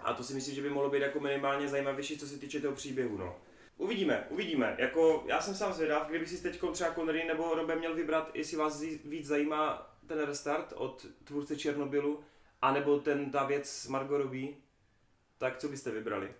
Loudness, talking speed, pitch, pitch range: -34 LUFS, 190 wpm, 145 Hz, 140-155 Hz